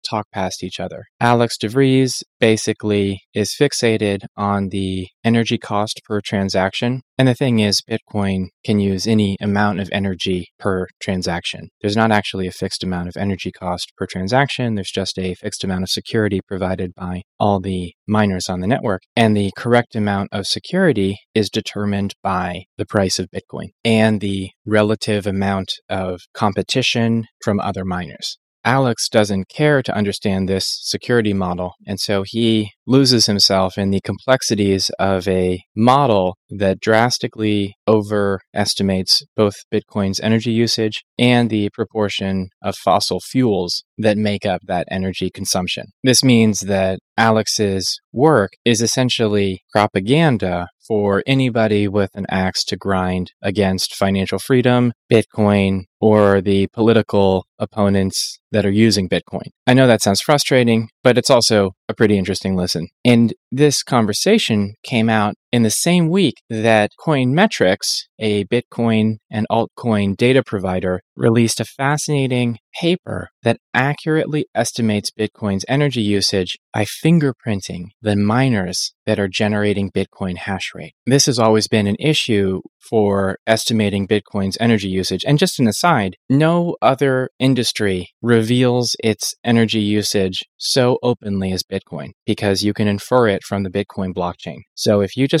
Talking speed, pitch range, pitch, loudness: 145 wpm, 95-115 Hz, 105 Hz, -18 LUFS